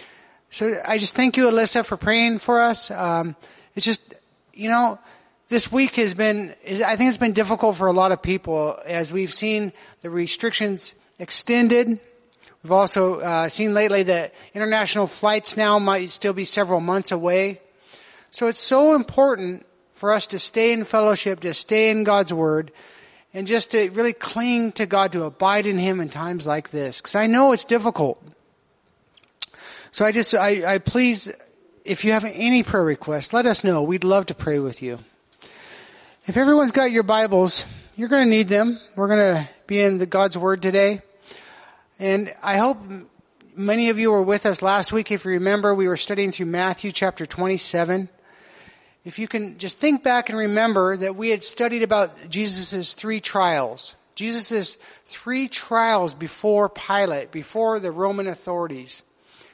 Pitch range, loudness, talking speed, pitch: 185-225 Hz, -20 LUFS, 170 wpm, 205 Hz